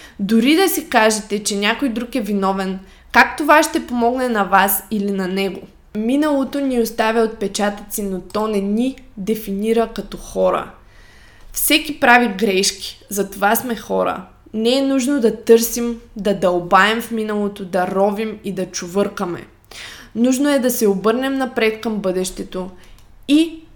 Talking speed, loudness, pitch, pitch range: 145 wpm, -18 LUFS, 215 Hz, 195-240 Hz